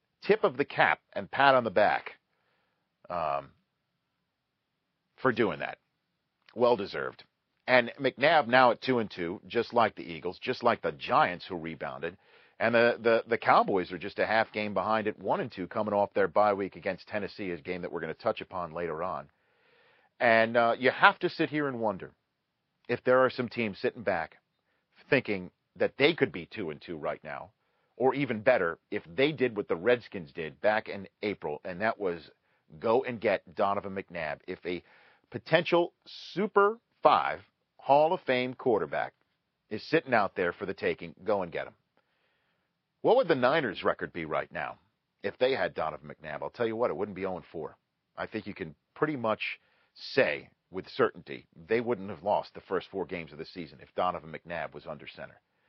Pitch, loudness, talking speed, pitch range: 115 Hz, -29 LUFS, 195 wpm, 100-130 Hz